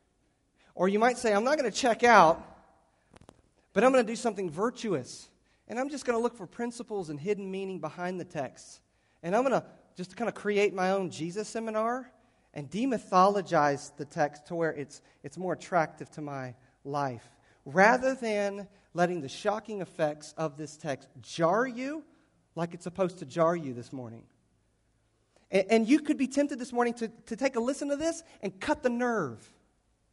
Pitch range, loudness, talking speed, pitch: 155-235 Hz, -29 LUFS, 185 wpm, 190 Hz